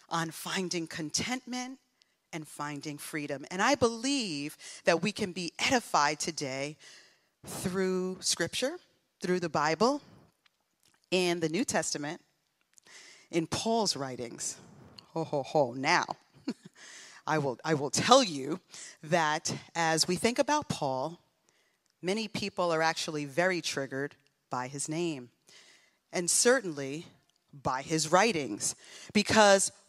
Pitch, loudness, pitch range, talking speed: 170 Hz, -30 LUFS, 150-200 Hz, 115 wpm